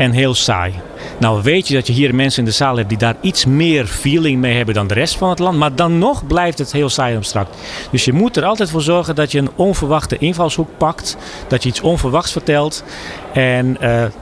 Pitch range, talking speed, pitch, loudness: 120-165 Hz, 235 wpm, 140 Hz, -15 LUFS